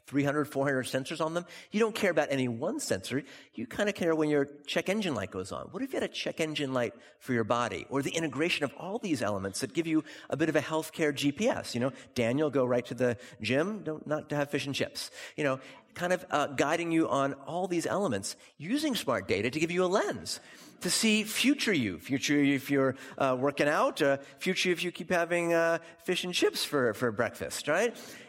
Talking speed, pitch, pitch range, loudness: 230 wpm, 155 Hz, 135-175 Hz, -30 LUFS